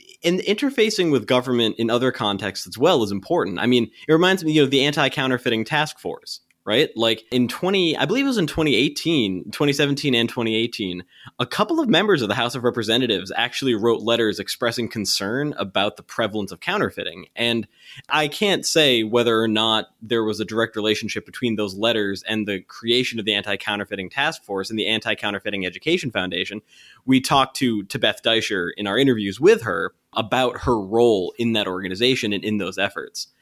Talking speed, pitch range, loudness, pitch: 190 wpm, 105-130 Hz, -21 LUFS, 115 Hz